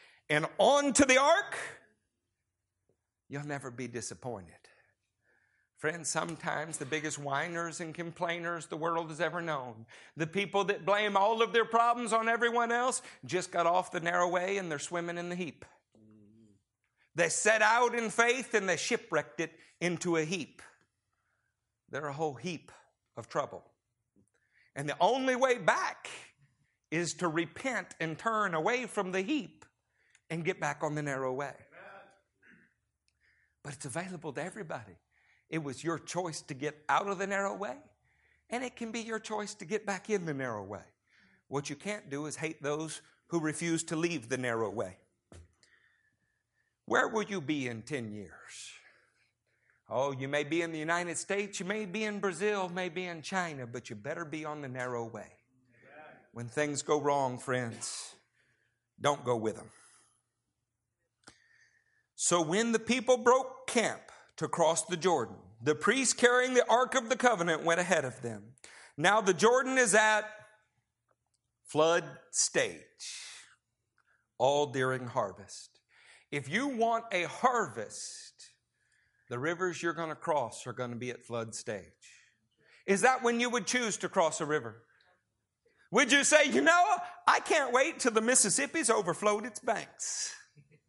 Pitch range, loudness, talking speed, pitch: 145-215 Hz, -31 LUFS, 160 wpm, 170 Hz